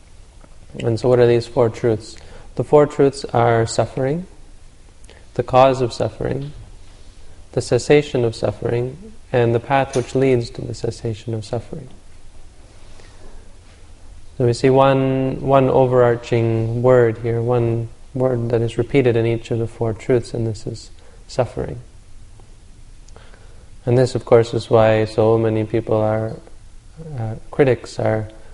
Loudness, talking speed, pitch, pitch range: -18 LUFS, 140 wpm, 115 Hz, 105-125 Hz